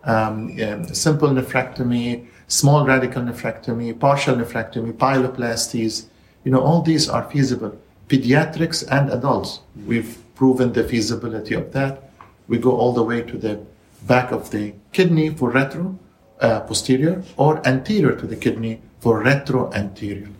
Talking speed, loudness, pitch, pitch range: 140 wpm, -20 LUFS, 125 Hz, 115-135 Hz